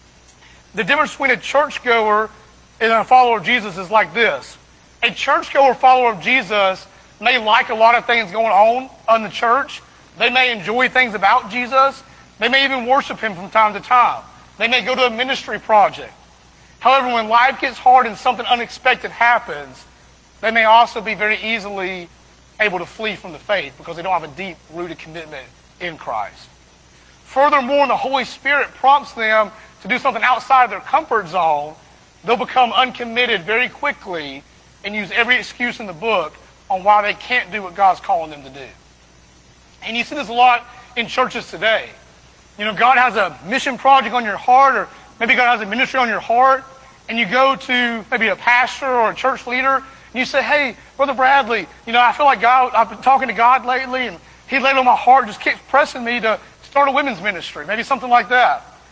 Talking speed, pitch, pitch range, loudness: 200 wpm, 235 Hz, 210-260 Hz, -16 LUFS